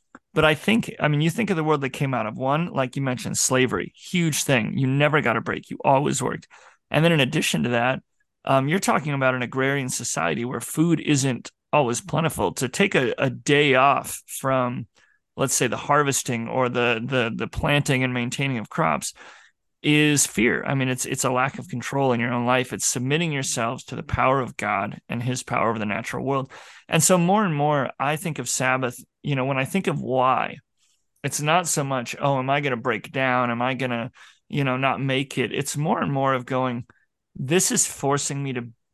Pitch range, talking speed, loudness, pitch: 125-150 Hz, 220 wpm, -23 LUFS, 135 Hz